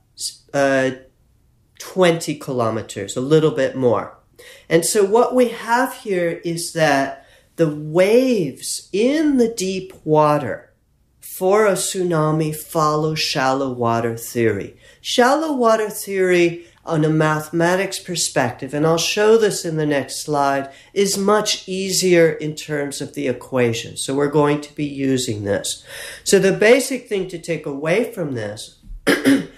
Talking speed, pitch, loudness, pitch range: 135 wpm, 155 Hz, -19 LUFS, 135-190 Hz